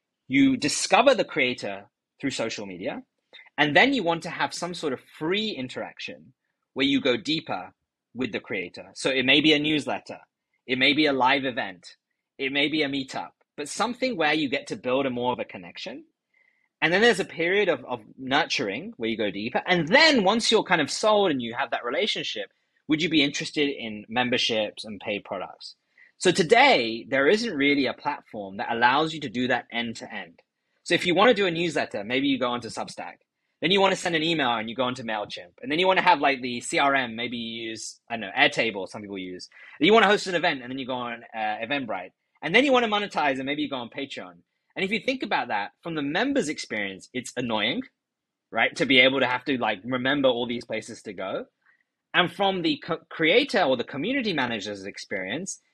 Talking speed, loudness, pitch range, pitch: 220 wpm, -24 LUFS, 125-185 Hz, 145 Hz